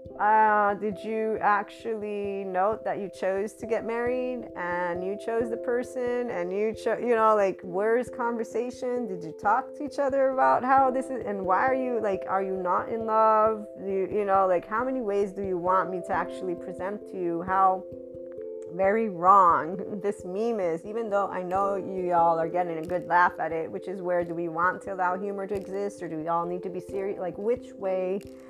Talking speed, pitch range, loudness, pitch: 215 wpm, 180-225 Hz, -27 LUFS, 195 Hz